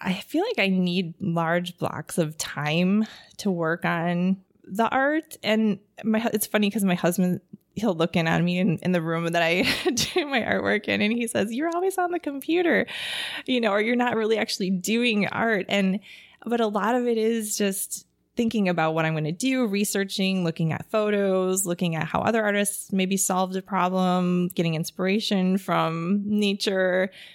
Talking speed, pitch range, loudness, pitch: 185 wpm, 180-220 Hz, -24 LUFS, 195 Hz